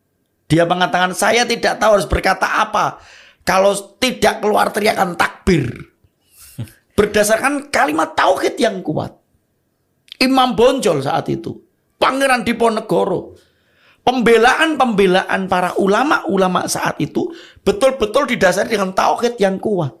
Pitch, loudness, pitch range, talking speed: 215 Hz, -16 LUFS, 190-255 Hz, 110 wpm